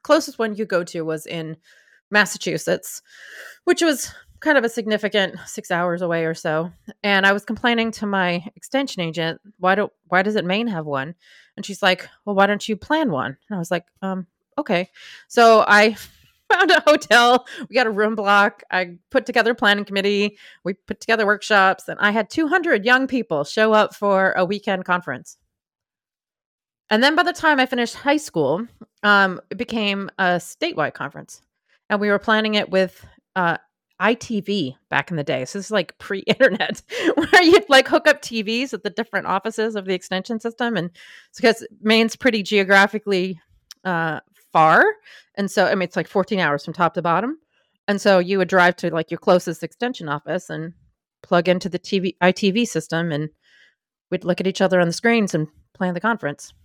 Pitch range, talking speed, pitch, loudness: 180-230 Hz, 190 wpm, 200 Hz, -19 LUFS